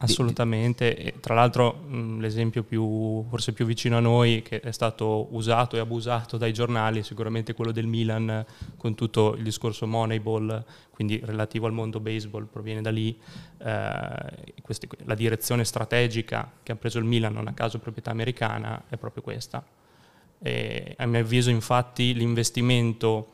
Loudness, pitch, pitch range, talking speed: -27 LUFS, 115 Hz, 110-120 Hz, 160 wpm